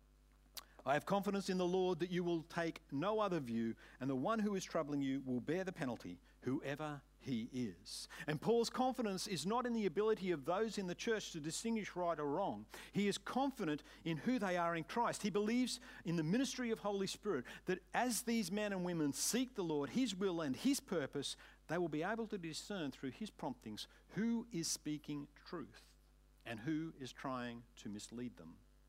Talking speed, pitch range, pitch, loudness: 200 wpm, 150-215 Hz, 180 Hz, -41 LUFS